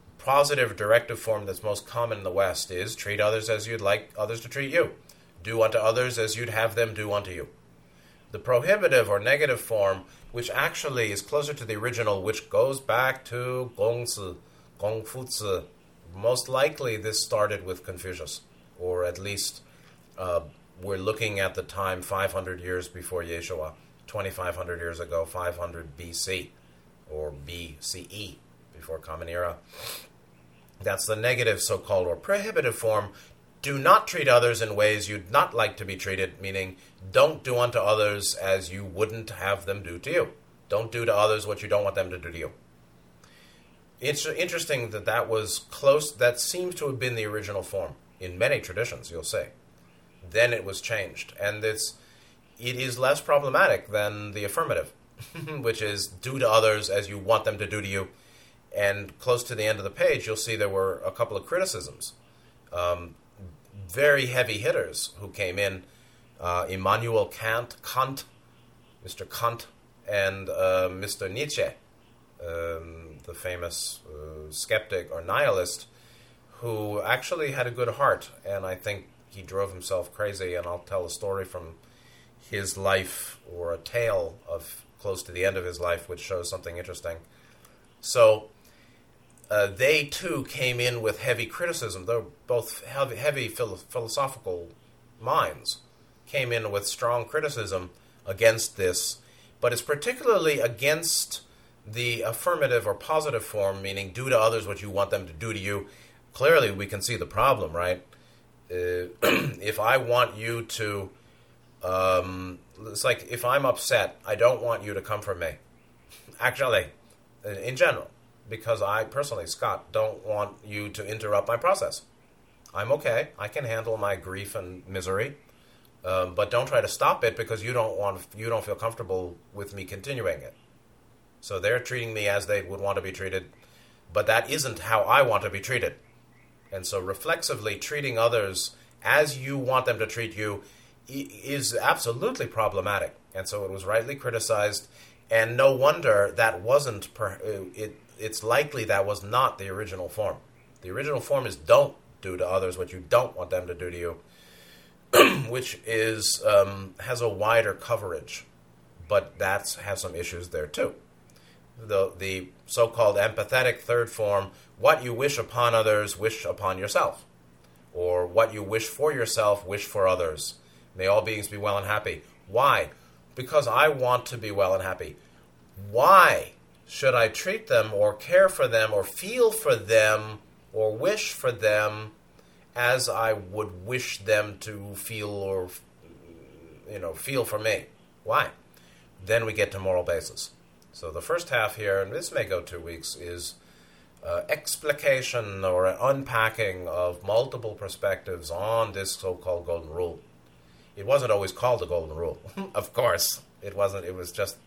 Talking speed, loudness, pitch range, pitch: 165 wpm, -27 LUFS, 90-120 Hz, 105 Hz